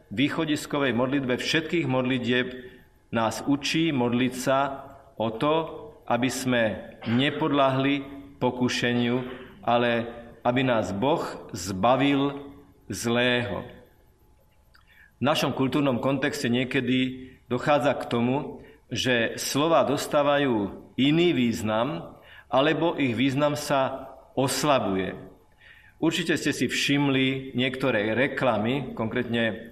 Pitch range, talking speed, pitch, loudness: 125-140 Hz, 90 wpm, 130 Hz, -25 LUFS